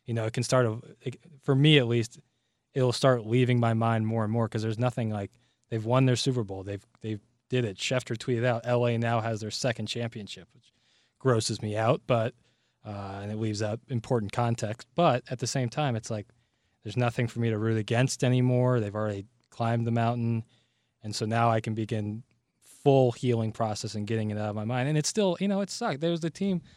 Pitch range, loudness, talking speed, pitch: 110-125 Hz, -28 LUFS, 220 wpm, 115 Hz